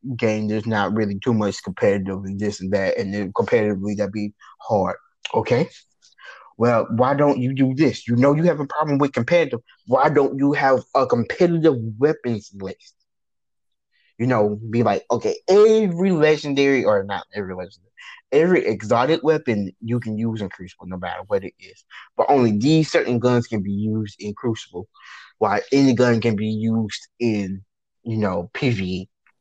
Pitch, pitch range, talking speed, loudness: 115 Hz, 105-140 Hz, 170 wpm, -20 LUFS